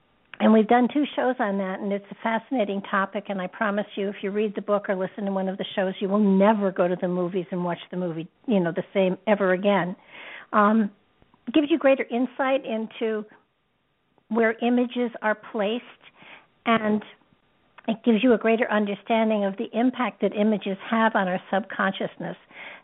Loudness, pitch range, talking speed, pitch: -24 LUFS, 195-235 Hz, 190 wpm, 210 Hz